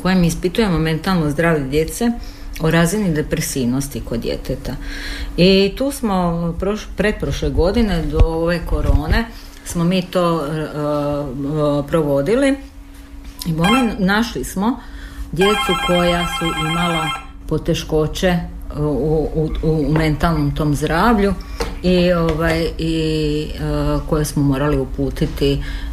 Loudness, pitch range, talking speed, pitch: -18 LUFS, 150-180 Hz, 110 wpm, 160 Hz